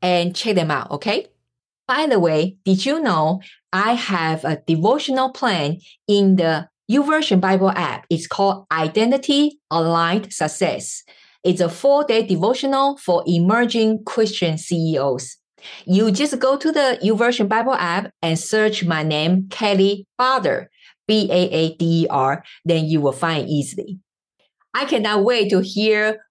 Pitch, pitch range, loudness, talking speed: 190 Hz, 165-220 Hz, -19 LUFS, 135 wpm